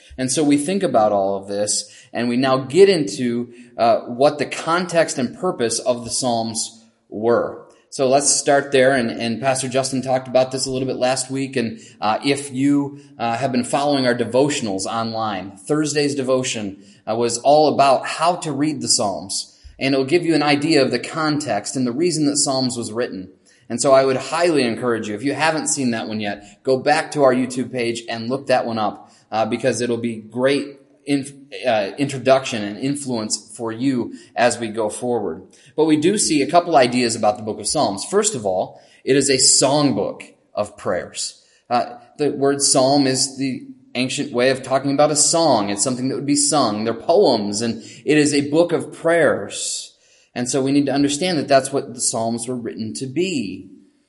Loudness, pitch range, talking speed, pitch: -19 LUFS, 115-145 Hz, 205 wpm, 130 Hz